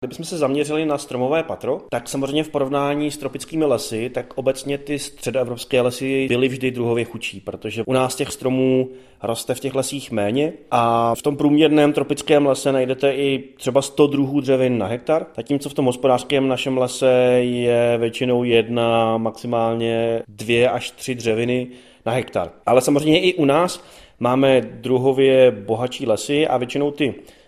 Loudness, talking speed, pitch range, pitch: -20 LUFS, 160 wpm, 120-140 Hz, 130 Hz